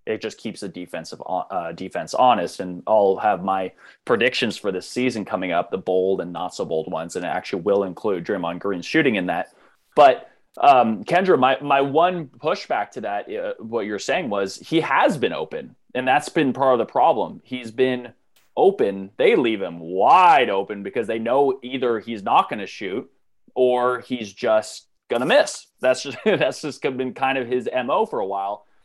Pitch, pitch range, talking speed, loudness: 125 Hz, 100-135 Hz, 195 wpm, -21 LUFS